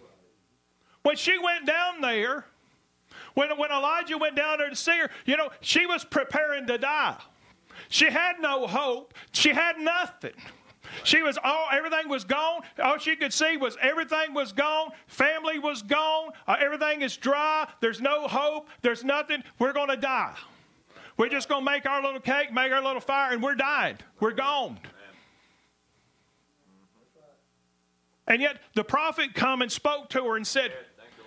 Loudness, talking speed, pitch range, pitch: -26 LUFS, 160 wpm, 255-310 Hz, 280 Hz